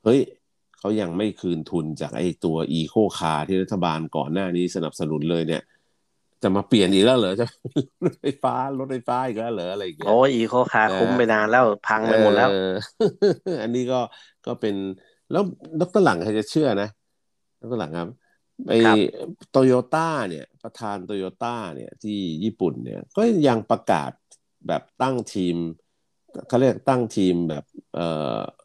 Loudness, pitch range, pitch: -22 LUFS, 90-125 Hz, 105 Hz